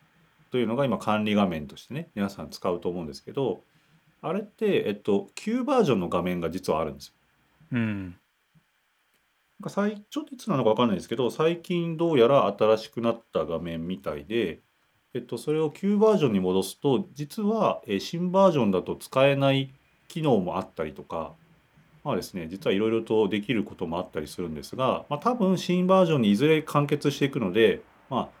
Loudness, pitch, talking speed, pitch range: -26 LUFS, 140 Hz, 340 characters per minute, 105-170 Hz